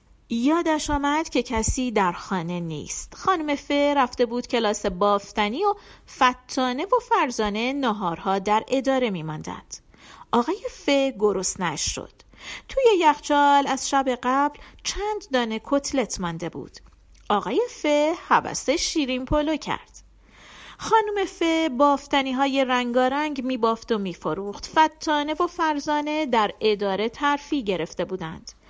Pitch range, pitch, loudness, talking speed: 215-300 Hz, 265 Hz, -23 LUFS, 125 wpm